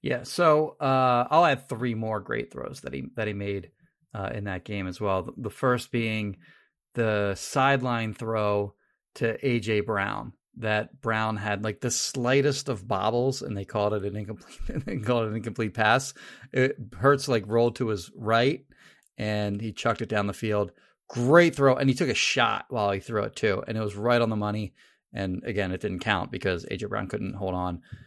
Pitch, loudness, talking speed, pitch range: 110 Hz, -27 LUFS, 200 wpm, 105-125 Hz